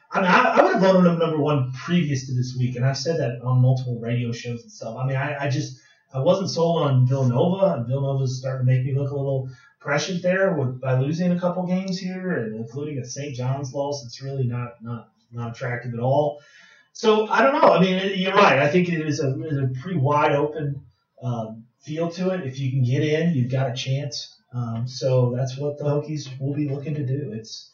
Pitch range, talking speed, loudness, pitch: 125-155 Hz, 240 wpm, -22 LUFS, 140 Hz